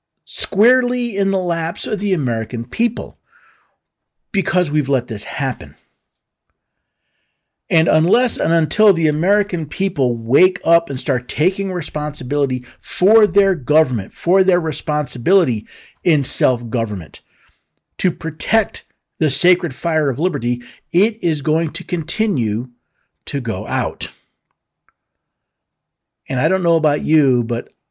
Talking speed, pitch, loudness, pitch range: 125 wpm, 160 Hz, -18 LUFS, 130-185 Hz